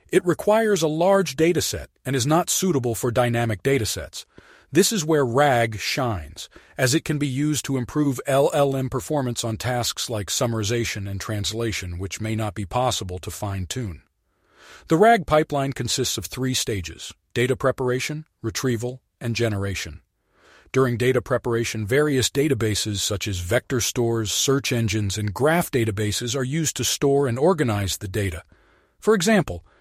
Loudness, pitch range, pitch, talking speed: -22 LUFS, 105-140 Hz, 125 Hz, 155 wpm